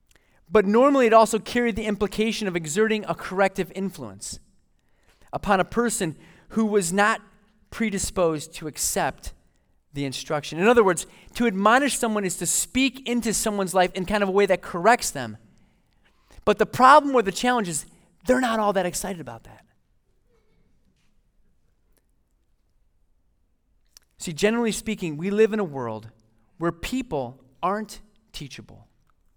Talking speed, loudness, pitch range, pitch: 140 wpm, -23 LUFS, 150-220 Hz, 195 Hz